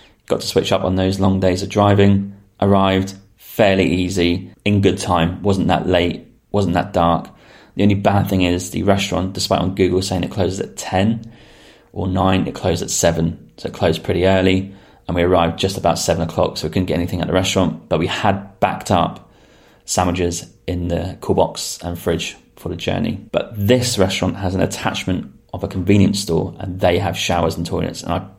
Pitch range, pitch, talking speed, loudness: 90-100 Hz, 95 Hz, 205 wpm, -18 LUFS